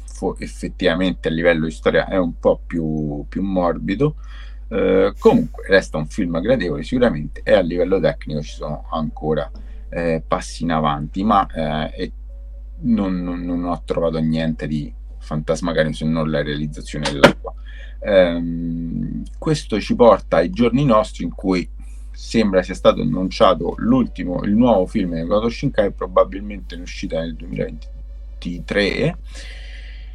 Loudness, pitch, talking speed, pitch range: -19 LUFS, 80 Hz, 135 wpm, 65-90 Hz